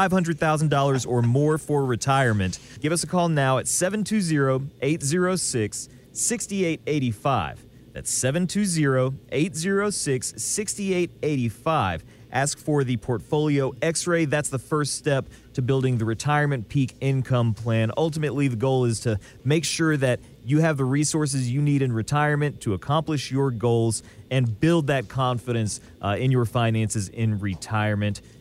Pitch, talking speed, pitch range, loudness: 135 Hz, 135 wpm, 120-155 Hz, -24 LUFS